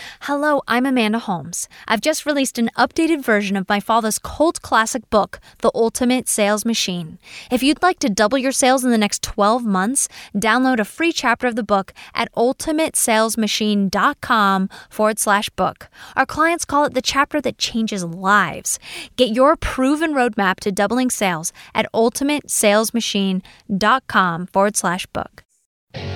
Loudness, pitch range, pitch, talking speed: -18 LUFS, 205-265 Hz, 230 Hz, 150 wpm